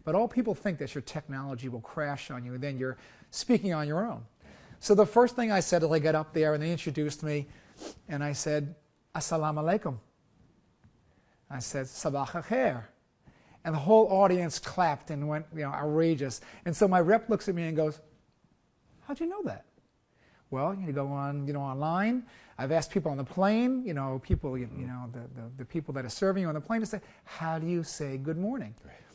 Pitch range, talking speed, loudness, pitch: 140-190 Hz, 215 wpm, -30 LUFS, 155 Hz